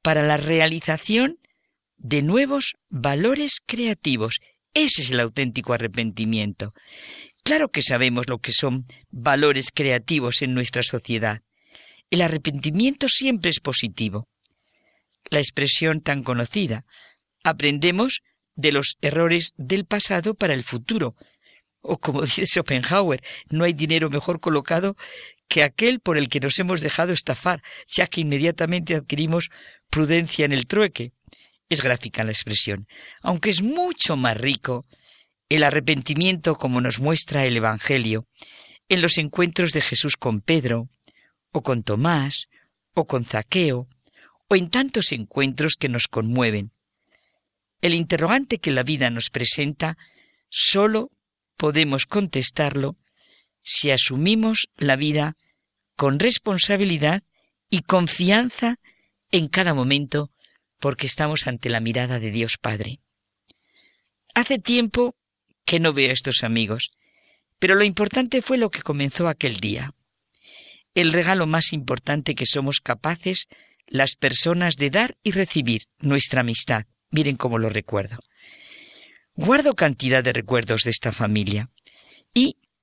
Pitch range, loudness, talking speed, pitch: 125-175 Hz, -21 LUFS, 125 wpm, 150 Hz